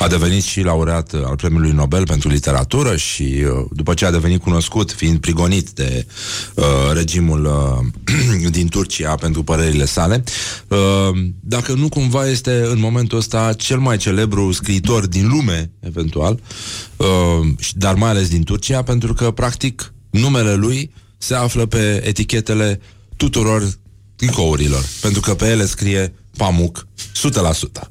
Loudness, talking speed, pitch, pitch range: -17 LUFS, 140 wpm, 100 Hz, 85-110 Hz